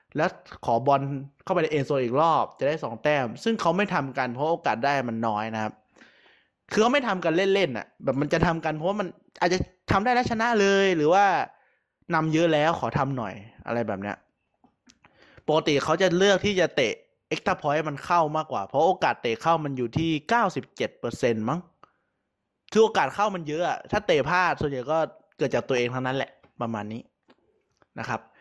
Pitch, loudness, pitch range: 155 Hz, -25 LUFS, 130-185 Hz